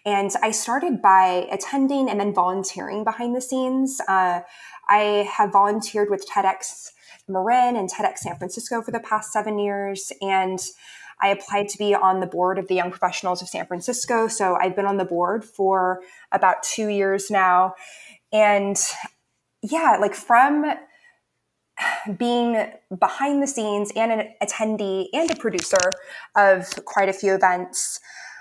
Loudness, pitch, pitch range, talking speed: -22 LUFS, 200 Hz, 190-225 Hz, 150 wpm